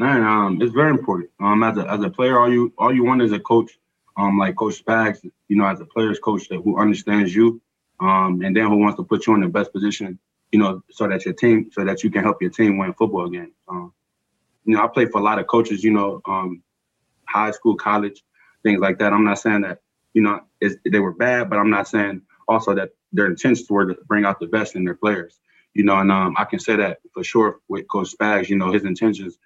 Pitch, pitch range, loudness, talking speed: 105 Hz, 95-110 Hz, -19 LUFS, 255 wpm